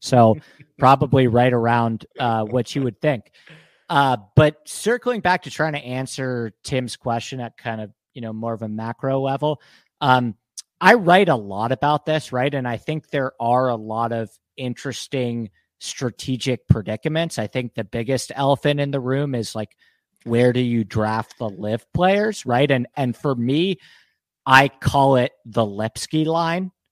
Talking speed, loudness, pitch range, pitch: 170 wpm, -21 LUFS, 115-145 Hz, 130 Hz